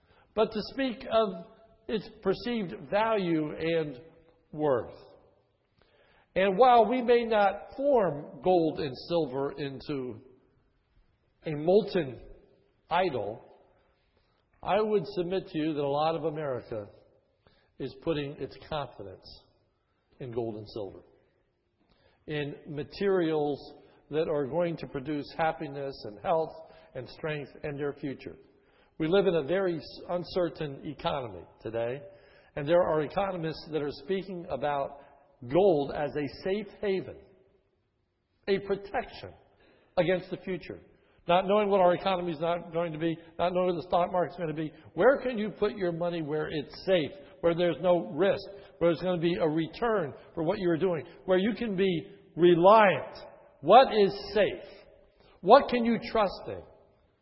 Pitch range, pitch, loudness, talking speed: 150-195 Hz, 170 Hz, -29 LUFS, 145 wpm